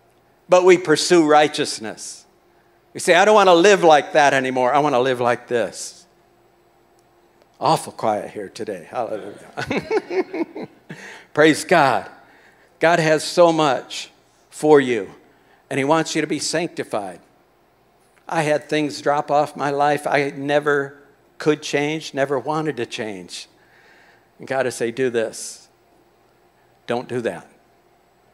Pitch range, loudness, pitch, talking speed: 135-160 Hz, -19 LUFS, 150 Hz, 135 wpm